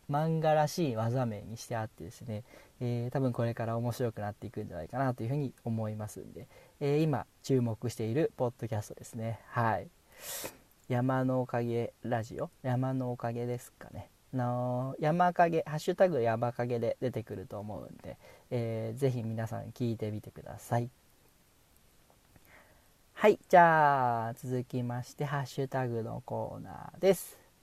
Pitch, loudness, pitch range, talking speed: 120 Hz, -32 LUFS, 115-135 Hz, 325 characters per minute